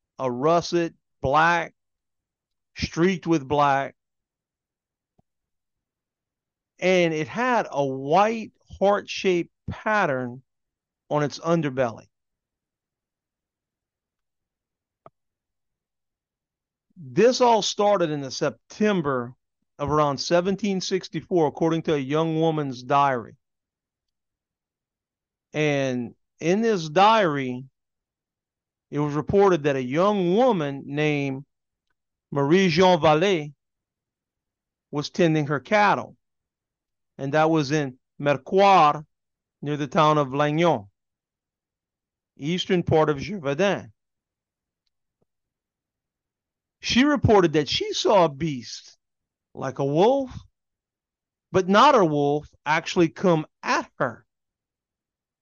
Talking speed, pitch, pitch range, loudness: 90 wpm, 155 Hz, 135-180 Hz, -22 LUFS